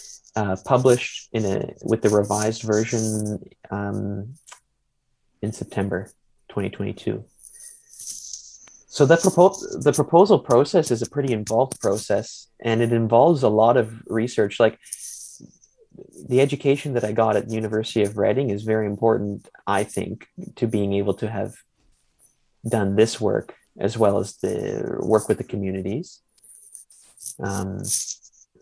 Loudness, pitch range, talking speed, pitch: -22 LUFS, 100-120 Hz, 130 wpm, 110 Hz